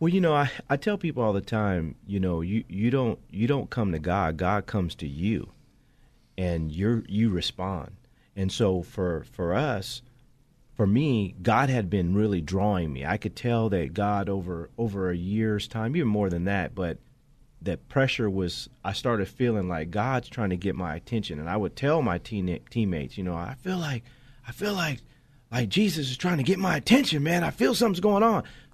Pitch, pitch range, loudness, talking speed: 110 Hz, 95-130 Hz, -27 LUFS, 205 wpm